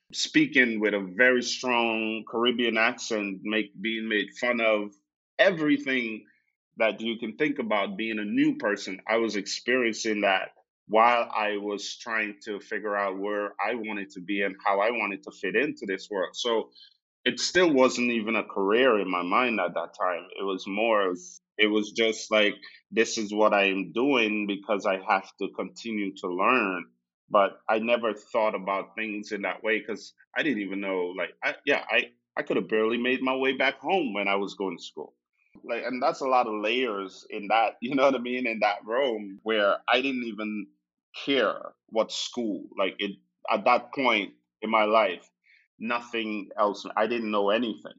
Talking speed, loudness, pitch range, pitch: 190 wpm, -26 LUFS, 100-120 Hz, 110 Hz